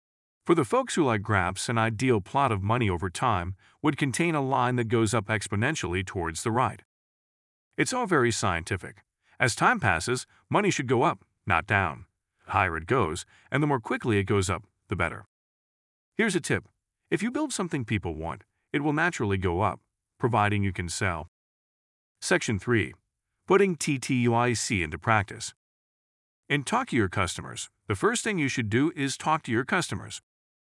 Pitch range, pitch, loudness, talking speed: 100-135 Hz, 110 Hz, -27 LUFS, 175 wpm